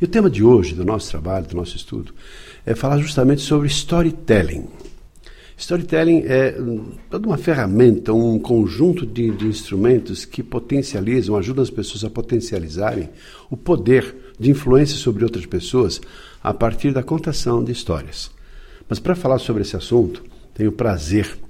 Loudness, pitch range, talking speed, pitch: -19 LUFS, 105-140 Hz, 155 wpm, 120 Hz